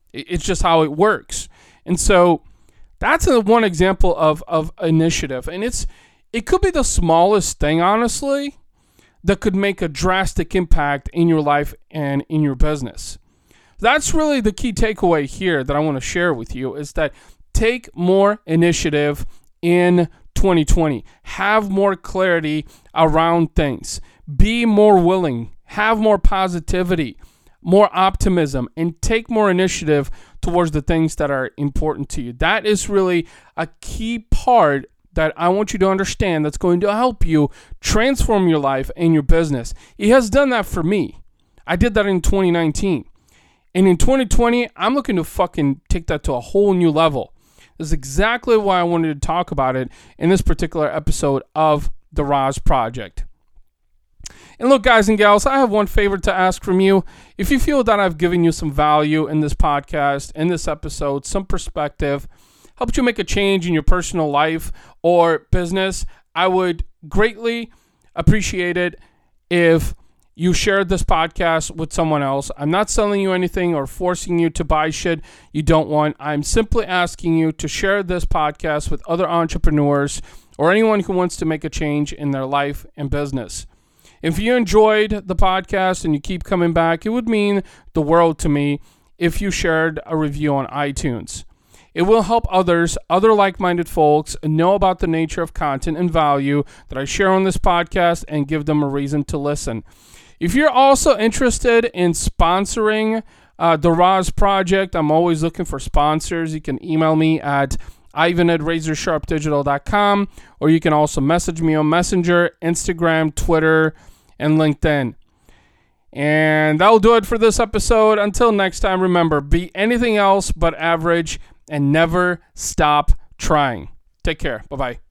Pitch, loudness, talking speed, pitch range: 170 Hz, -18 LUFS, 165 wpm, 150-195 Hz